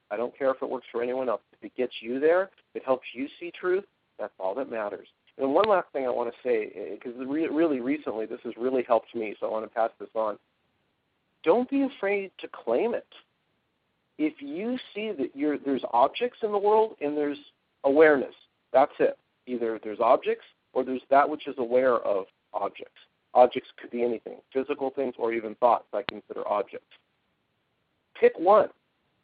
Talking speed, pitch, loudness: 190 wpm, 140 Hz, -27 LUFS